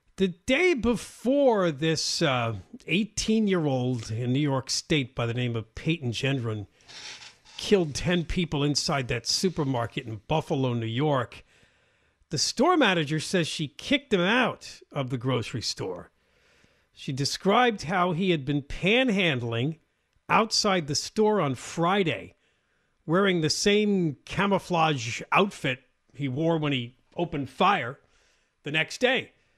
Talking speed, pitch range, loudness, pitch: 135 wpm, 125-190 Hz, -26 LUFS, 155 Hz